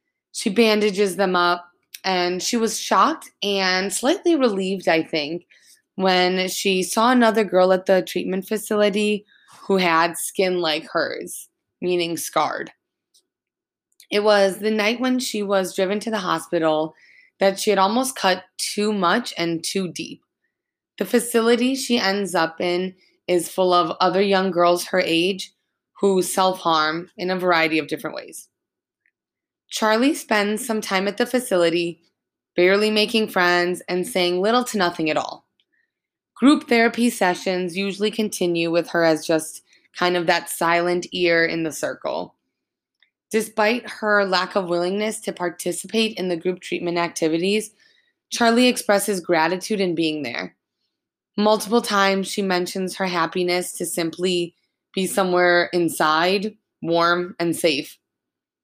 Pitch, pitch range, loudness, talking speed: 190 Hz, 175-215 Hz, -21 LUFS, 140 wpm